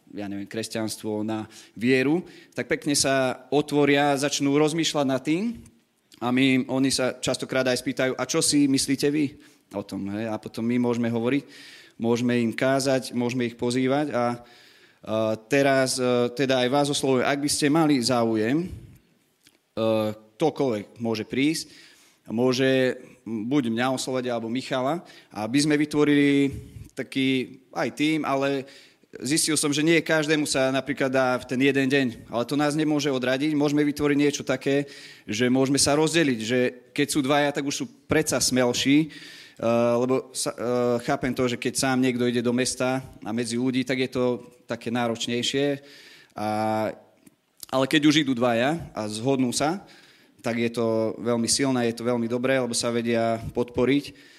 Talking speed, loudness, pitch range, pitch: 160 wpm, -24 LUFS, 120-145 Hz, 130 Hz